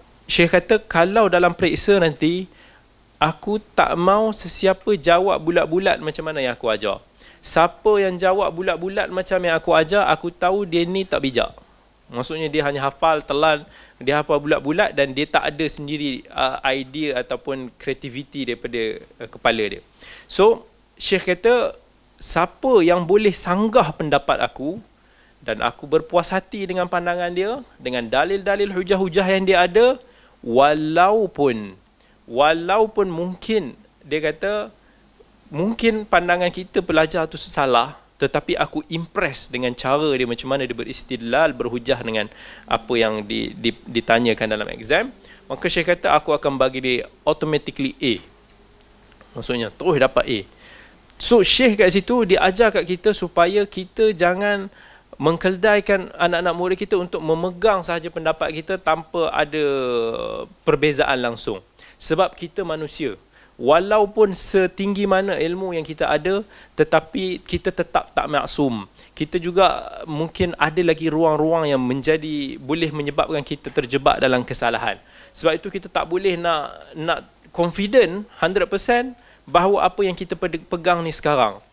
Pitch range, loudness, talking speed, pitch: 145-190 Hz, -20 LUFS, 135 wpm, 170 Hz